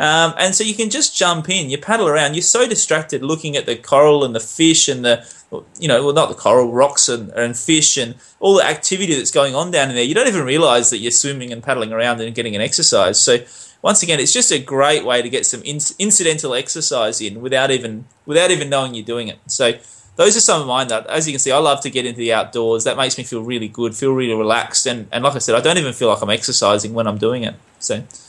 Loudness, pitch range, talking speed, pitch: -15 LUFS, 115-155 Hz, 265 wpm, 135 Hz